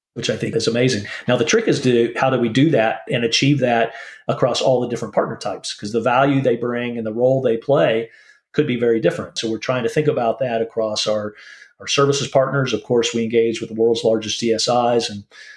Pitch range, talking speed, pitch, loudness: 115-130 Hz, 230 wpm, 120 Hz, -19 LUFS